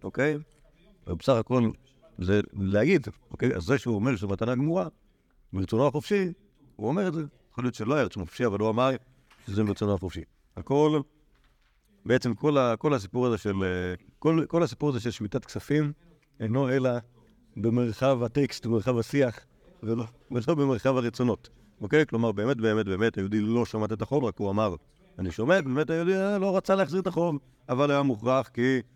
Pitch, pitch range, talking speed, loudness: 125 Hz, 110-145 Hz, 175 wpm, -27 LUFS